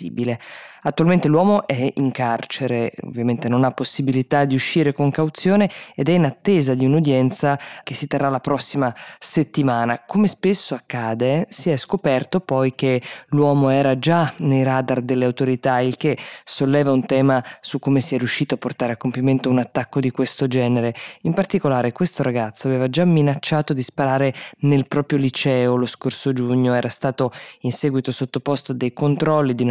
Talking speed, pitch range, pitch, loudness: 165 wpm, 125-145 Hz, 135 Hz, -20 LUFS